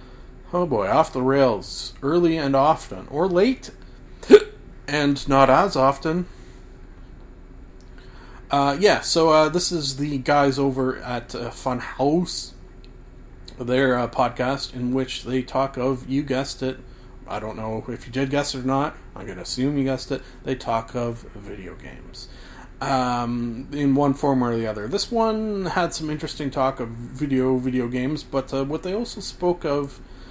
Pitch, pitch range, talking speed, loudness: 135 Hz, 125-145 Hz, 165 wpm, -22 LUFS